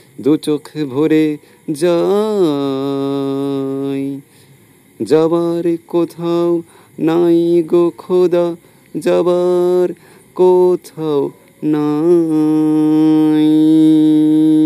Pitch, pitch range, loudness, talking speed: 155 Hz, 150-175 Hz, -14 LUFS, 50 wpm